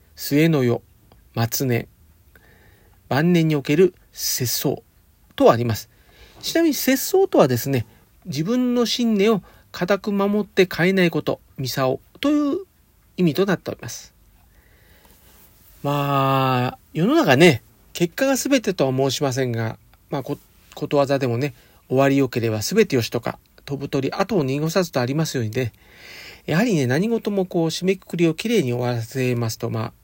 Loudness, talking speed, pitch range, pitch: -21 LUFS, 295 characters per minute, 115-185 Hz, 140 Hz